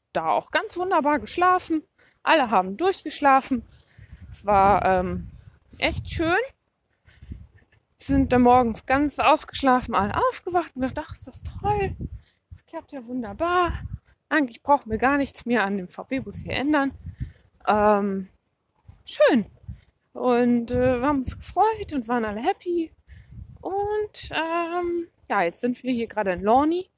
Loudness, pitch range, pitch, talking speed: -23 LUFS, 245-340 Hz, 275 Hz, 140 wpm